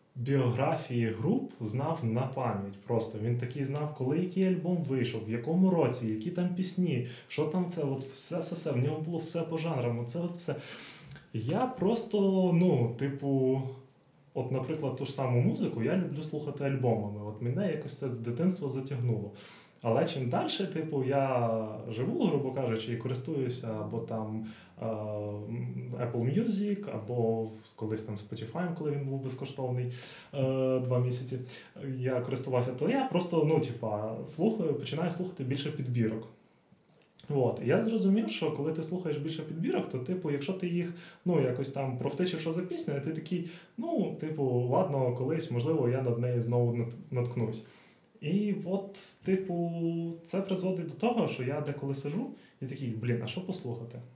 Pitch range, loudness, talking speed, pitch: 120-170 Hz, -32 LUFS, 155 wpm, 140 Hz